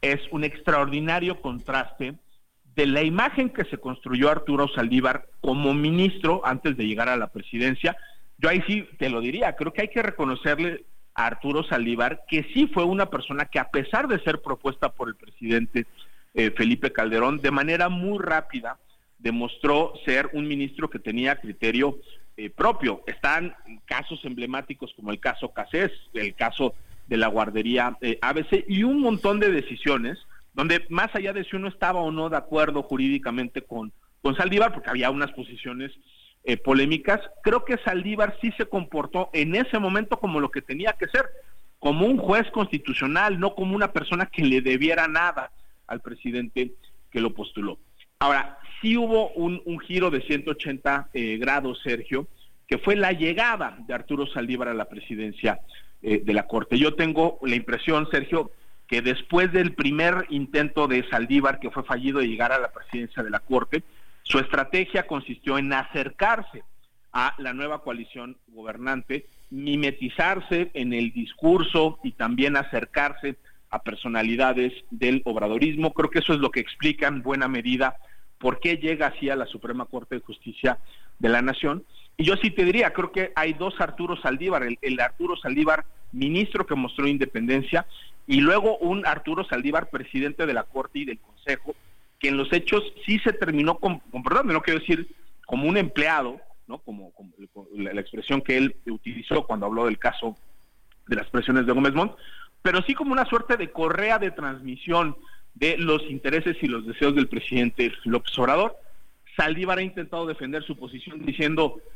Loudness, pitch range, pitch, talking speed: -25 LUFS, 125-175 Hz, 145 Hz, 170 wpm